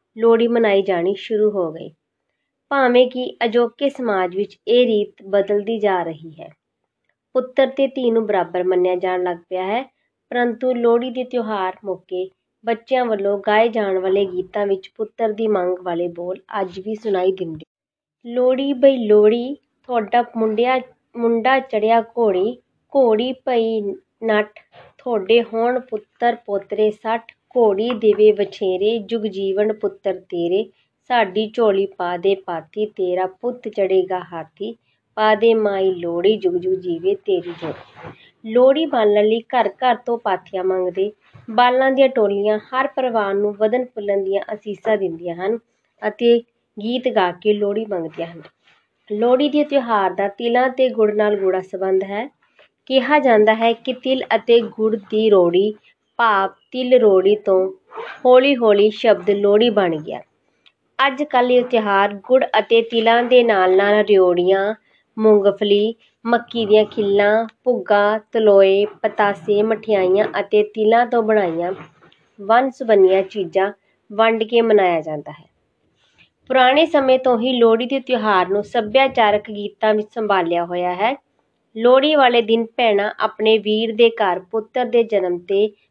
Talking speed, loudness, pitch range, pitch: 140 wpm, -18 LUFS, 195-240 Hz, 215 Hz